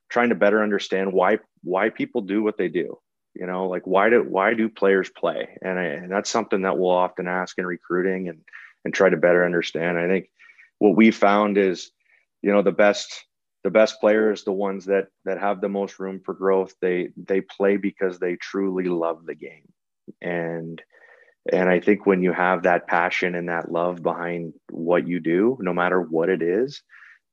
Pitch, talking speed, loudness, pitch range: 95 Hz, 200 wpm, -22 LUFS, 90-100 Hz